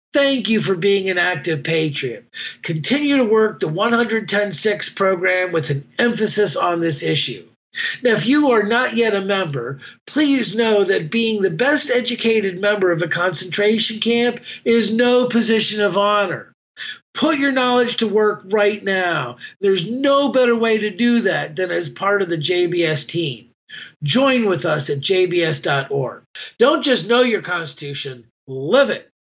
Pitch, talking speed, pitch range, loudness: 205 Hz, 160 wpm, 175-235 Hz, -17 LUFS